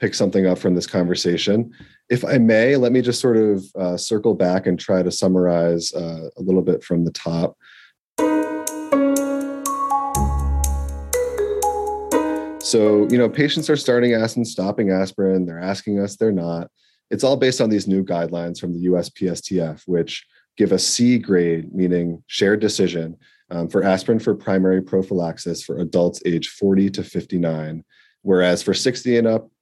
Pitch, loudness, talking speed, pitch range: 95 Hz, -20 LUFS, 155 wpm, 85-115 Hz